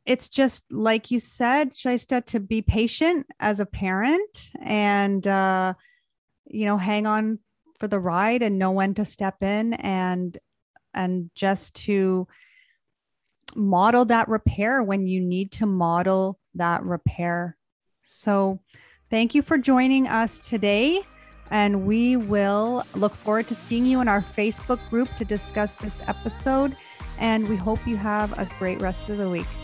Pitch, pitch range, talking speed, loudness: 210 Hz, 195-240 Hz, 150 wpm, -24 LUFS